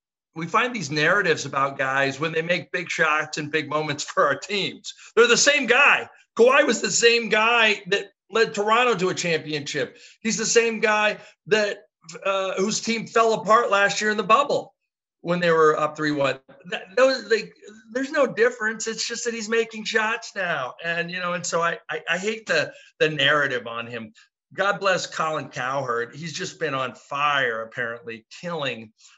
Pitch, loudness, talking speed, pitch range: 190 Hz, -22 LUFS, 180 wpm, 155-225 Hz